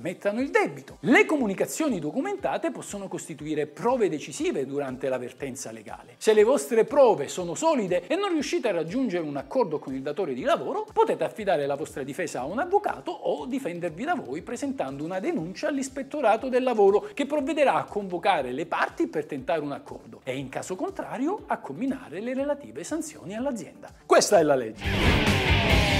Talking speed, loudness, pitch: 170 wpm, -26 LUFS, 260 Hz